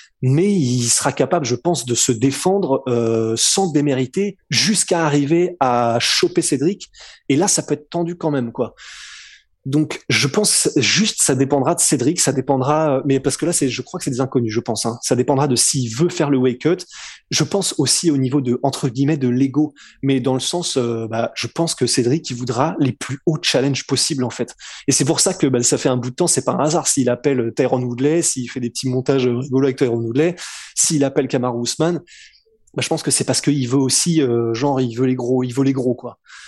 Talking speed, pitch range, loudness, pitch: 230 wpm, 125-160 Hz, -18 LUFS, 135 Hz